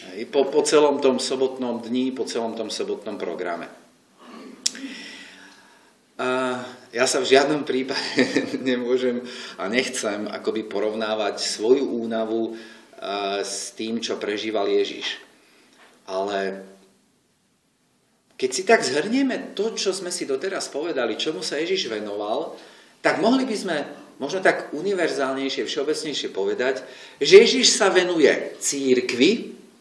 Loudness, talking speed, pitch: -22 LUFS, 115 wpm, 150 Hz